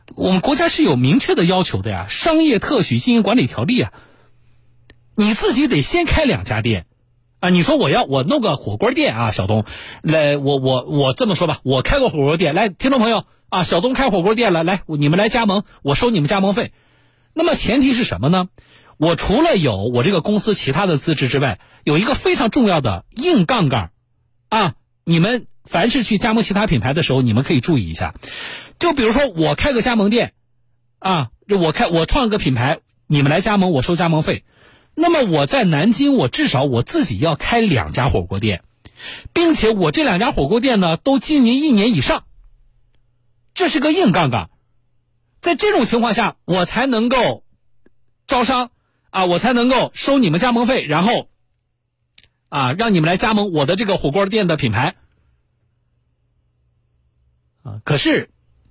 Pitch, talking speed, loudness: 170 Hz, 265 characters per minute, -16 LUFS